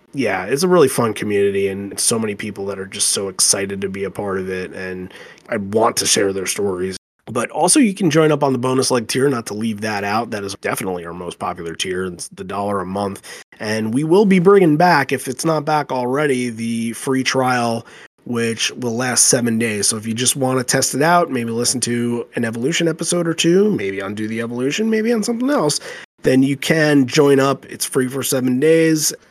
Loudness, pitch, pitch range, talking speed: -17 LUFS, 120 Hz, 100-145 Hz, 225 wpm